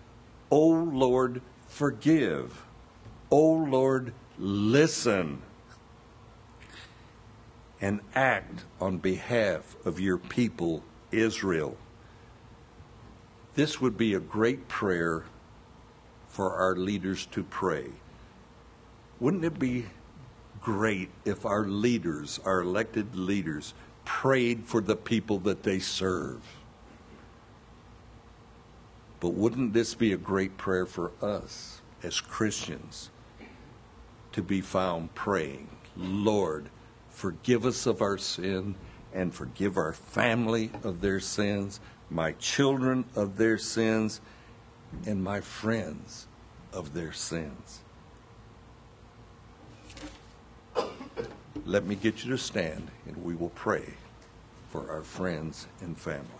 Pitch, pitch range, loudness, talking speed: 110 Hz, 95-115 Hz, -30 LUFS, 105 wpm